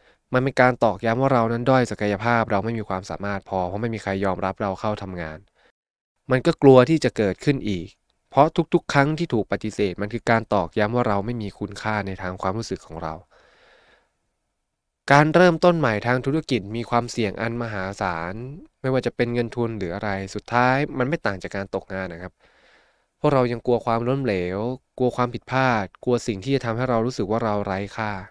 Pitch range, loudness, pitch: 100-125 Hz, -22 LUFS, 115 Hz